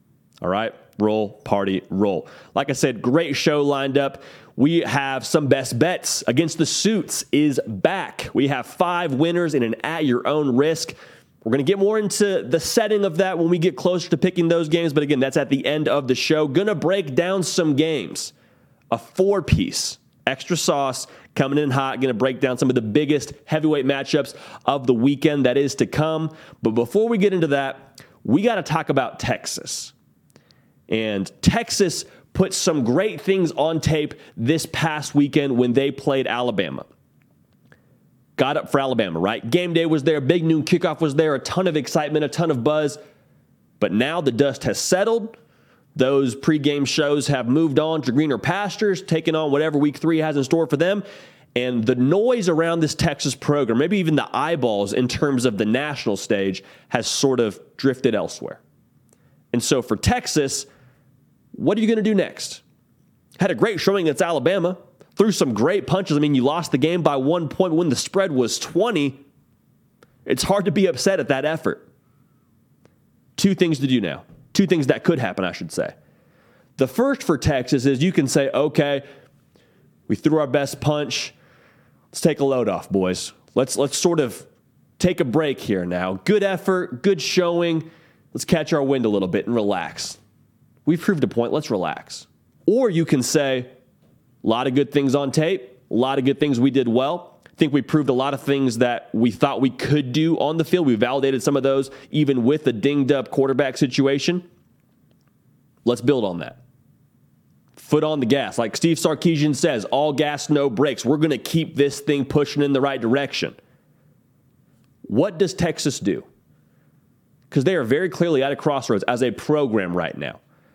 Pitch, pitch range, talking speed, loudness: 145 Hz, 135-165 Hz, 190 wpm, -21 LUFS